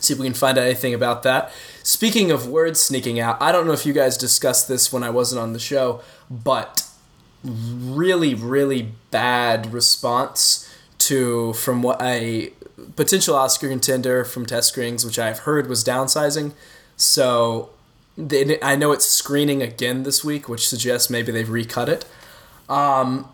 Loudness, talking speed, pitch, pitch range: -19 LUFS, 165 wpm, 125 Hz, 120-140 Hz